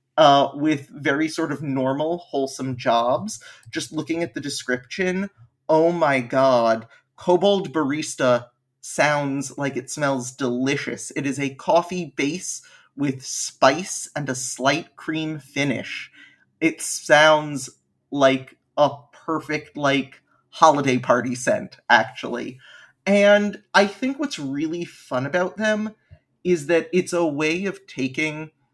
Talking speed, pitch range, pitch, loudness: 125 wpm, 135-165 Hz, 145 Hz, -22 LUFS